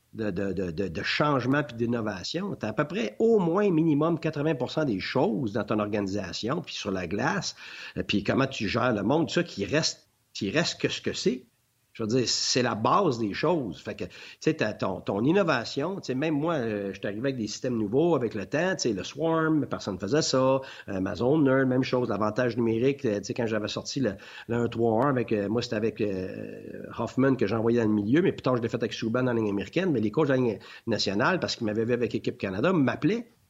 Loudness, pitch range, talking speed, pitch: -27 LUFS, 105-145 Hz, 220 wpm, 120 Hz